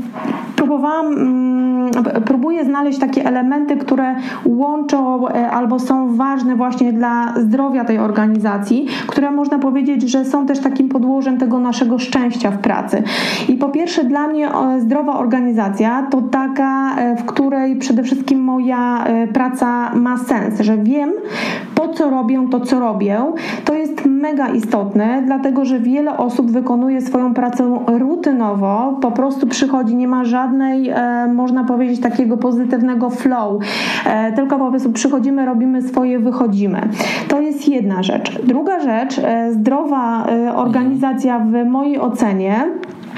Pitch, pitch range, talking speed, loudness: 255 Hz, 240-275 Hz, 130 wpm, -16 LUFS